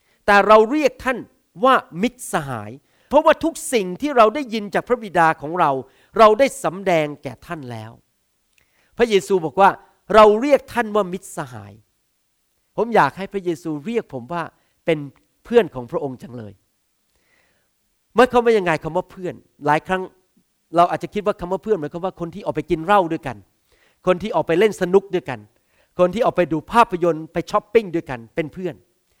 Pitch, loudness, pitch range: 180 Hz, -19 LUFS, 150-215 Hz